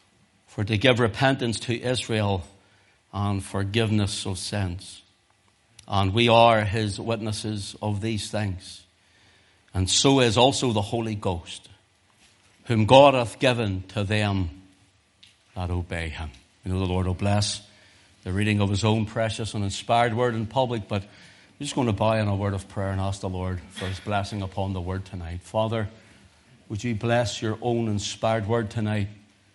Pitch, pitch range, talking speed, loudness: 105 Hz, 95-115 Hz, 165 wpm, -24 LUFS